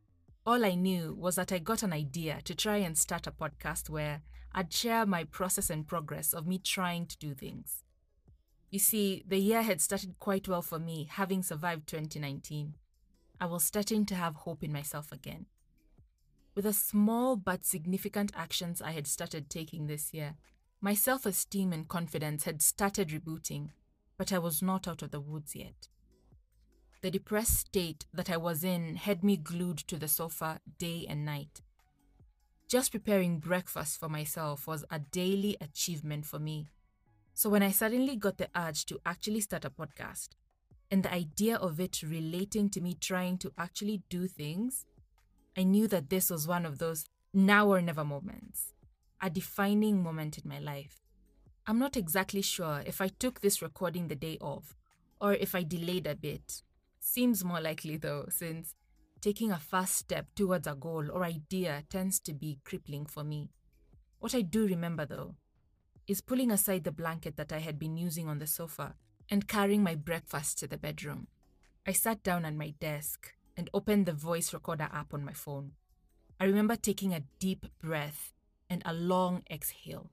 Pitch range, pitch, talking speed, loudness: 150-195 Hz, 170 Hz, 175 wpm, -33 LUFS